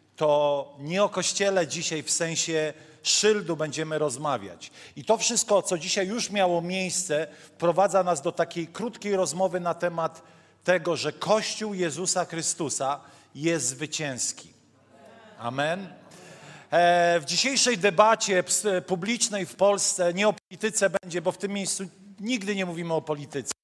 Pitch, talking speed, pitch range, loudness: 175 Hz, 135 wpm, 160-200 Hz, -25 LUFS